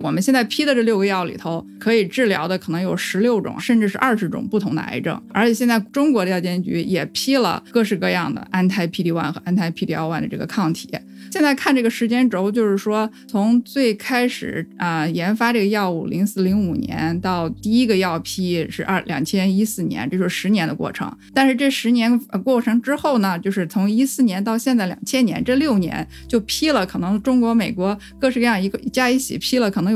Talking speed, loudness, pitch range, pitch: 325 characters per minute, -19 LUFS, 185-240 Hz, 215 Hz